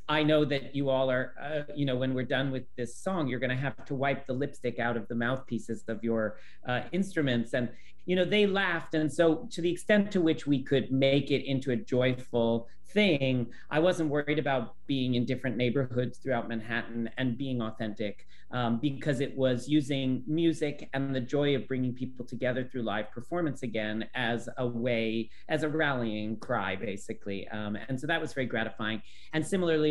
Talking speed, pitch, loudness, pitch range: 195 wpm, 130 Hz, -31 LUFS, 120-150 Hz